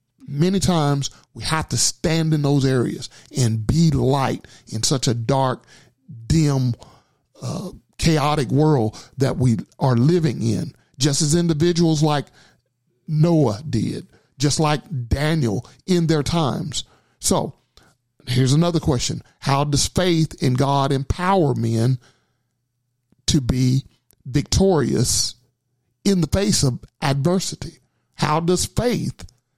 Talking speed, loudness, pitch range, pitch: 120 wpm, -20 LUFS, 125-160 Hz, 140 Hz